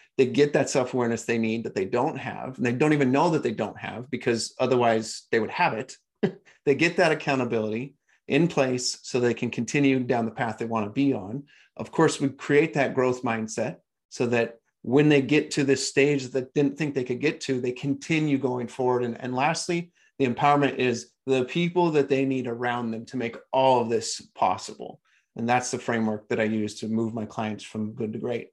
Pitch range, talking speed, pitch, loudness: 115-140 Hz, 220 wpm, 125 Hz, -25 LUFS